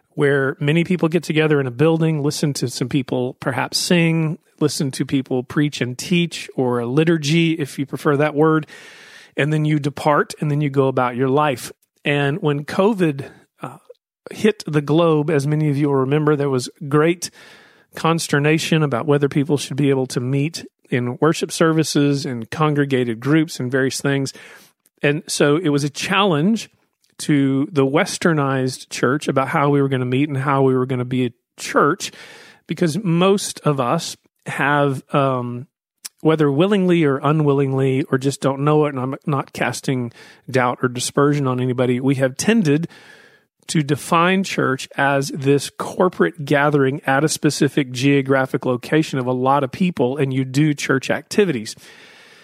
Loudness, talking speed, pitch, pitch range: -19 LUFS, 170 wpm, 145 Hz, 135-160 Hz